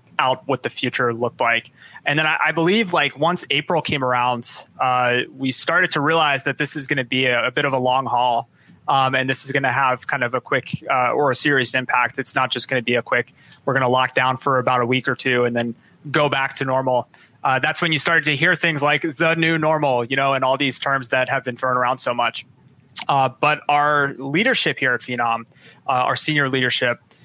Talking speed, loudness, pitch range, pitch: 245 wpm, -19 LUFS, 125-150 Hz, 135 Hz